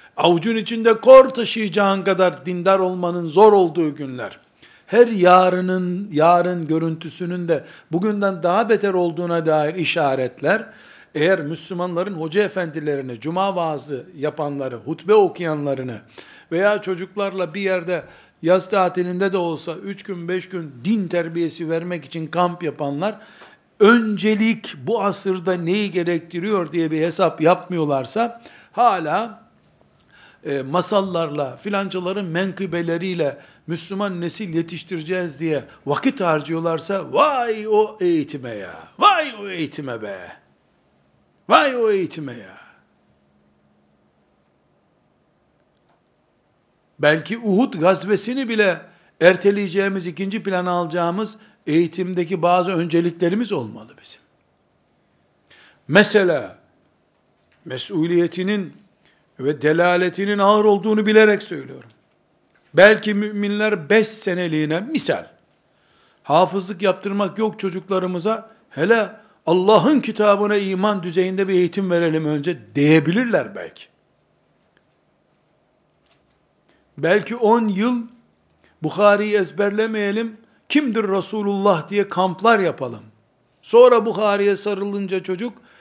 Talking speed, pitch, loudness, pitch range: 95 wpm, 185 Hz, -19 LUFS, 165-210 Hz